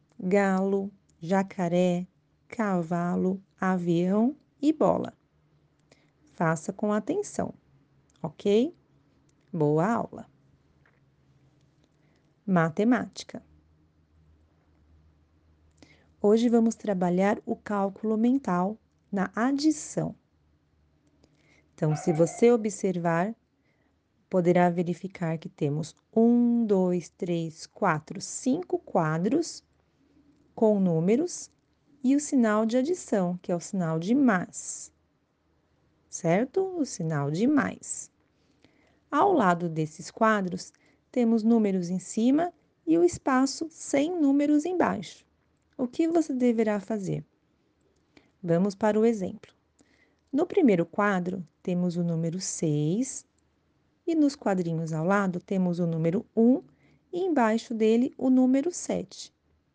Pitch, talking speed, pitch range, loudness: 200 Hz, 100 wpm, 175-245 Hz, -27 LUFS